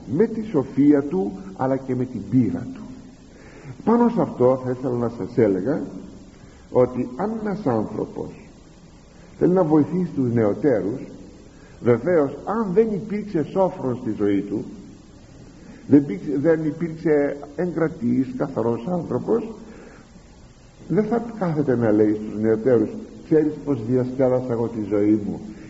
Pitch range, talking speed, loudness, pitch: 115-180 Hz, 130 wpm, -22 LUFS, 140 Hz